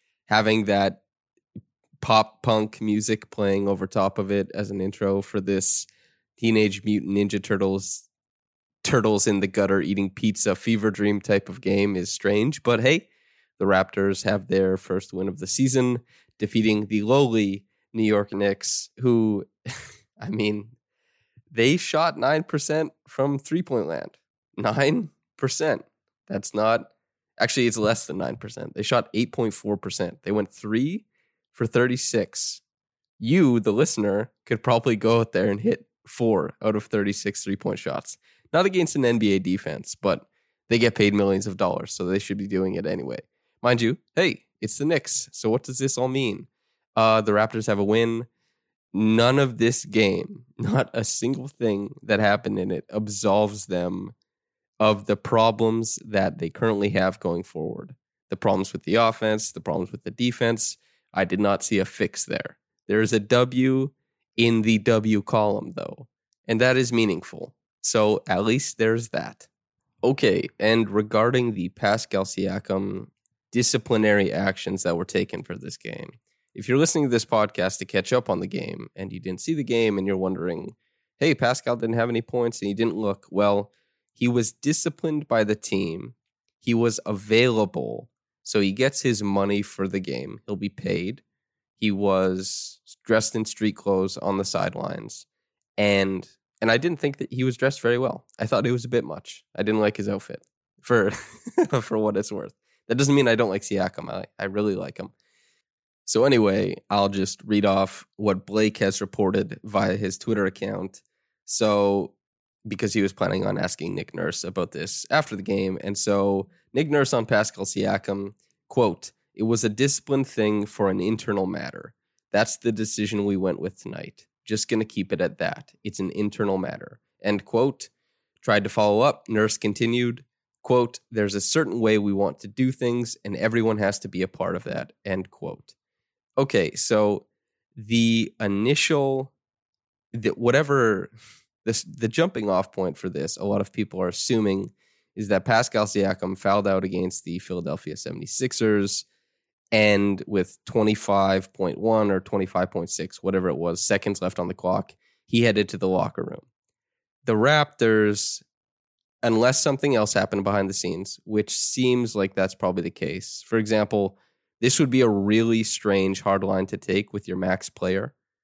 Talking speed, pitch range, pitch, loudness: 170 wpm, 100-115 Hz, 105 Hz, -24 LUFS